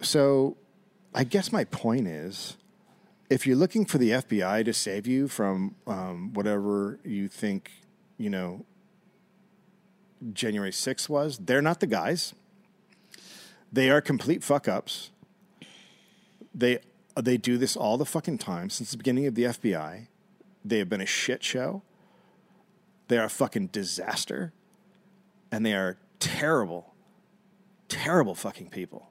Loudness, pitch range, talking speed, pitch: -28 LUFS, 125-200 Hz, 135 wpm, 180 Hz